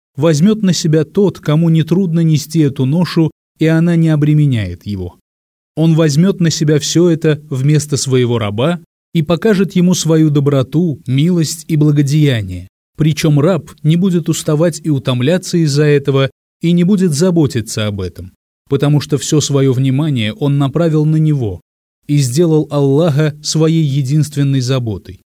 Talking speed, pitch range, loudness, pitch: 145 wpm, 135-165 Hz, -13 LUFS, 150 Hz